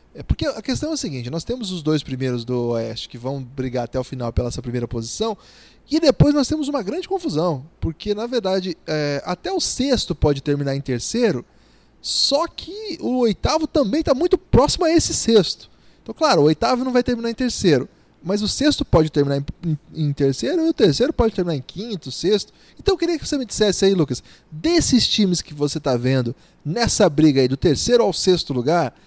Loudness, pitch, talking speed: -20 LUFS, 175 Hz, 210 wpm